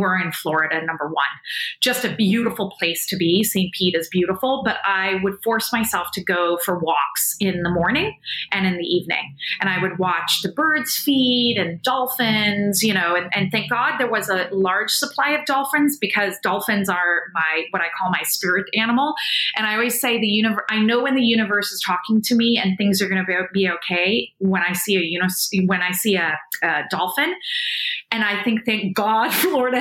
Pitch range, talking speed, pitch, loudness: 180-230 Hz, 205 wpm, 200 Hz, -20 LUFS